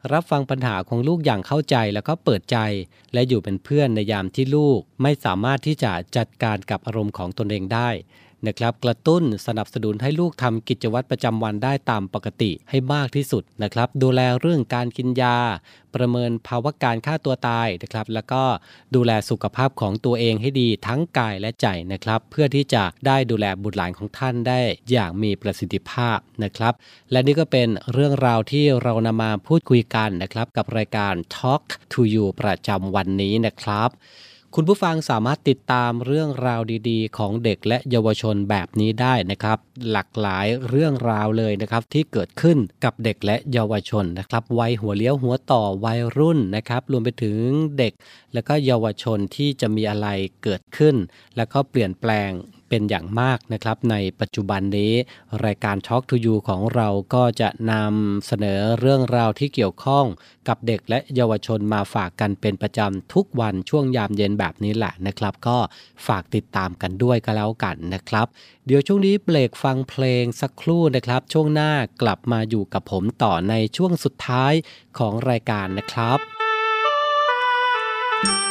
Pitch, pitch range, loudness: 115 Hz, 105-130 Hz, -21 LUFS